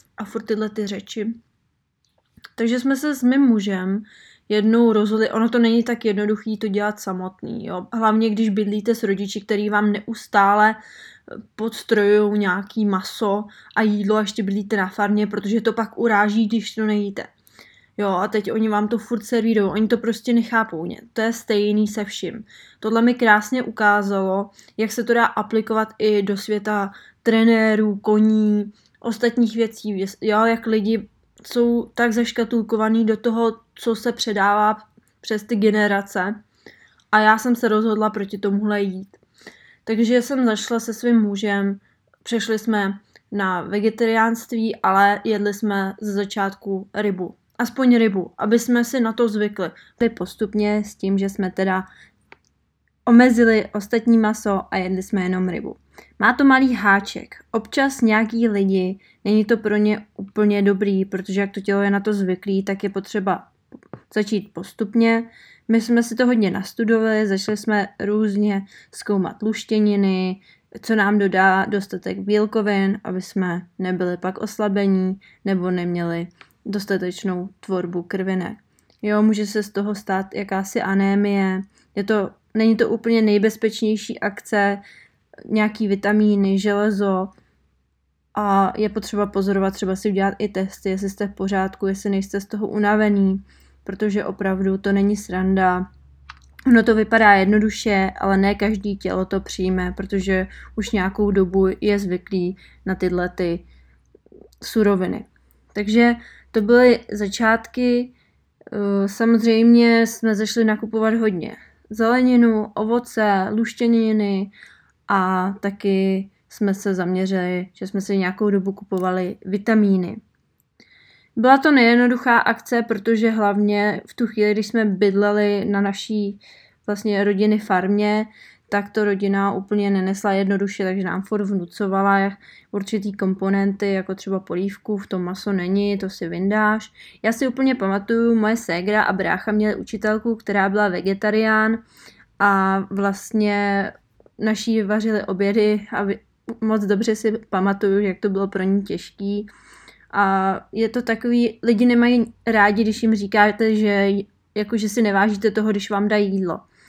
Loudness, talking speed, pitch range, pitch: -20 LUFS, 140 wpm, 195-220 Hz, 210 Hz